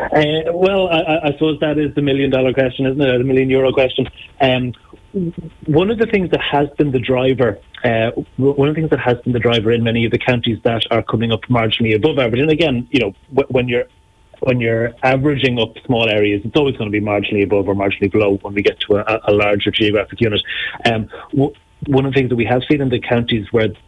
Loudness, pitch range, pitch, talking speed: -16 LUFS, 115-140 Hz, 125 Hz, 235 wpm